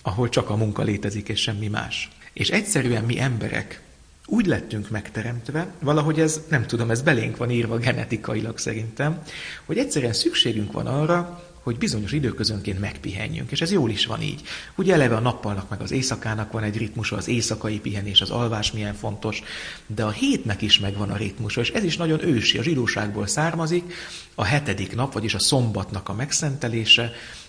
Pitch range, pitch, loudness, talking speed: 105-140 Hz, 115 Hz, -23 LUFS, 175 wpm